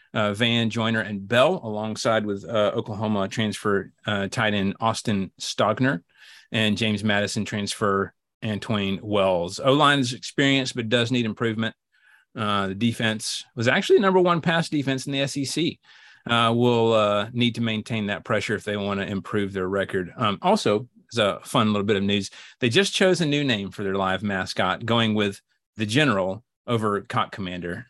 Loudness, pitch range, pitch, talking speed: -23 LUFS, 100-120 Hz, 110 Hz, 170 wpm